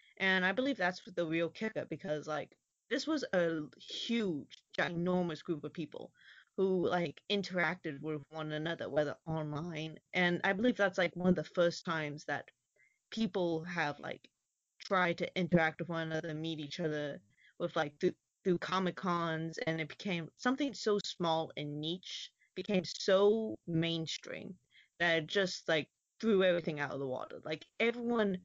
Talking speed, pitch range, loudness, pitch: 160 wpm, 160-190 Hz, -35 LUFS, 170 Hz